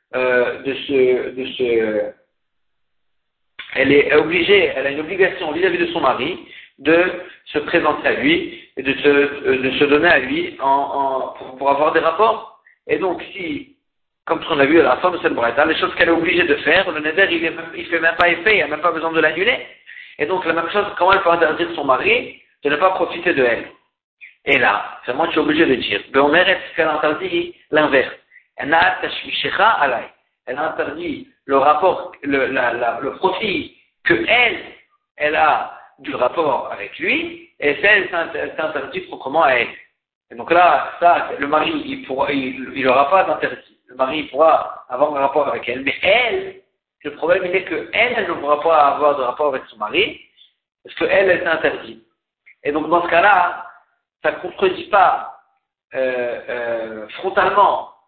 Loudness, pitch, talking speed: -17 LUFS, 170 Hz, 185 wpm